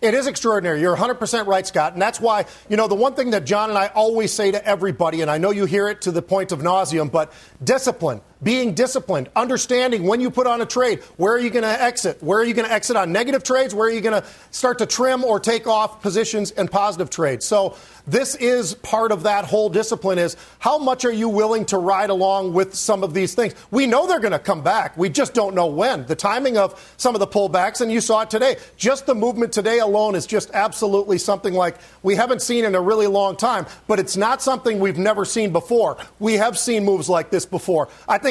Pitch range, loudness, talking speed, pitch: 190-235 Hz, -19 LUFS, 245 wpm, 210 Hz